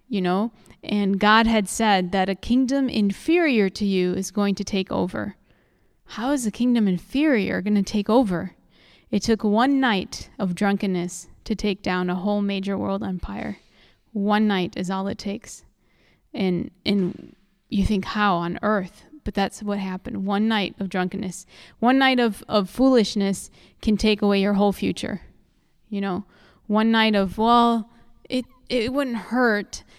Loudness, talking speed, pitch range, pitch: -23 LUFS, 165 wpm, 195-225 Hz, 205 Hz